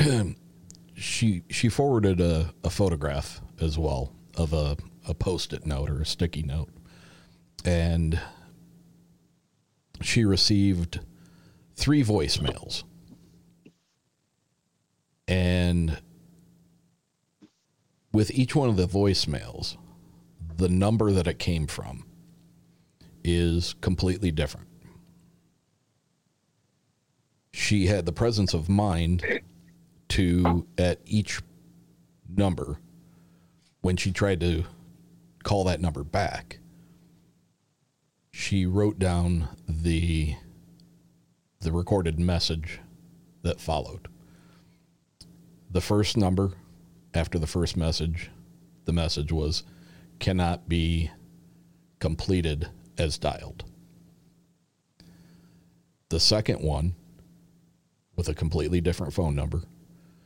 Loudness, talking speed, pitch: -27 LUFS, 90 wpm, 95 Hz